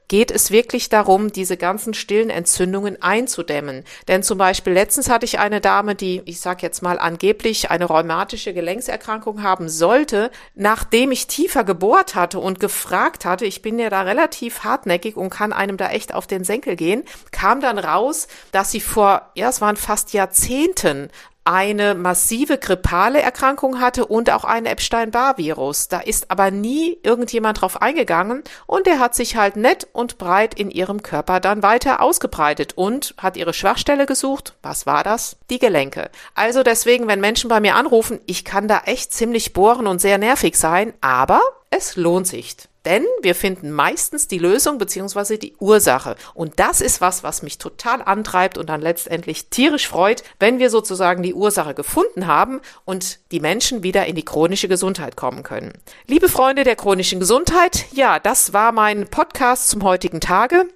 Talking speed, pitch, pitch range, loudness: 175 wpm, 205 Hz, 185-240 Hz, -17 LUFS